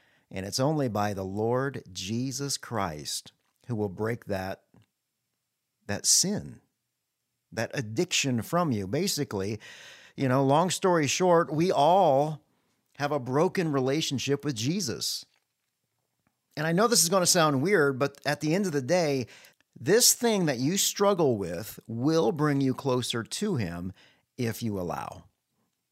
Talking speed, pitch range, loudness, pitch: 145 wpm, 115-160 Hz, -27 LUFS, 140 Hz